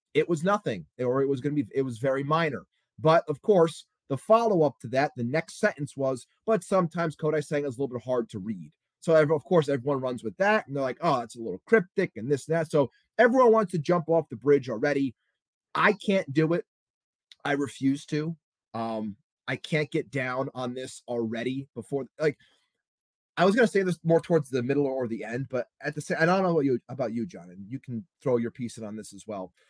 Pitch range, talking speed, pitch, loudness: 125-165 Hz, 235 wpm, 145 Hz, -27 LUFS